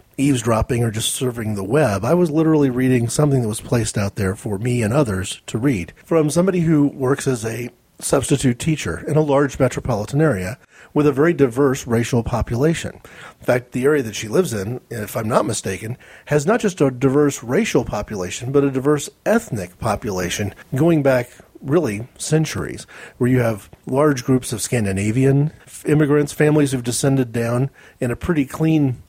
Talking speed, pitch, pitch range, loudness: 175 wpm, 130 Hz, 115-150 Hz, -19 LUFS